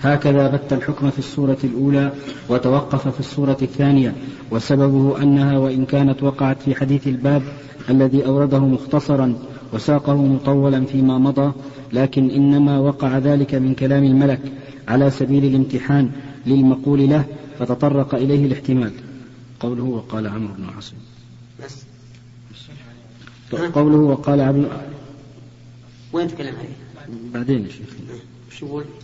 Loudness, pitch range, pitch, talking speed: -18 LUFS, 125-140 Hz, 135 Hz, 105 wpm